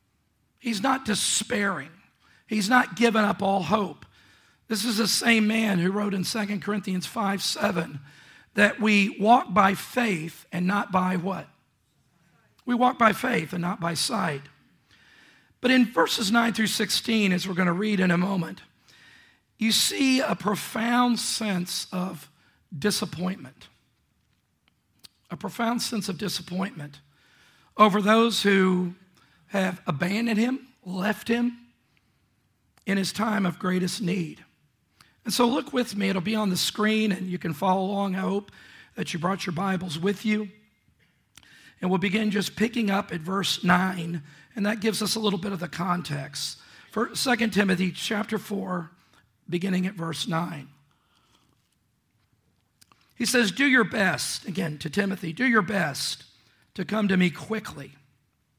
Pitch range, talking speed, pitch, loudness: 175-215 Hz, 150 wpm, 195 Hz, -25 LUFS